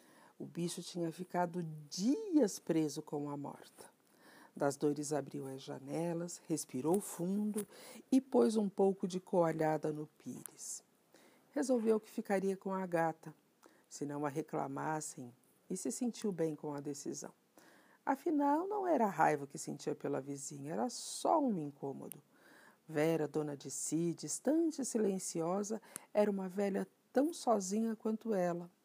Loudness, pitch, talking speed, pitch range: -37 LUFS, 175 Hz, 140 wpm, 155-220 Hz